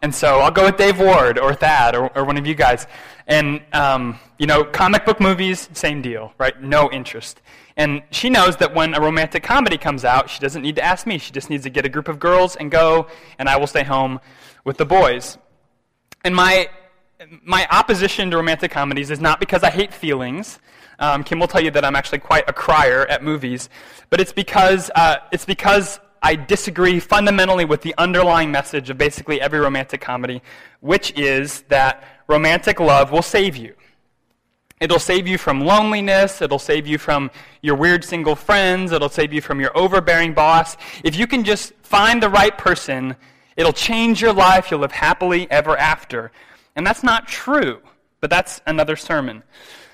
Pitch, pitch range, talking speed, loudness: 160 Hz, 145-185 Hz, 190 wpm, -16 LUFS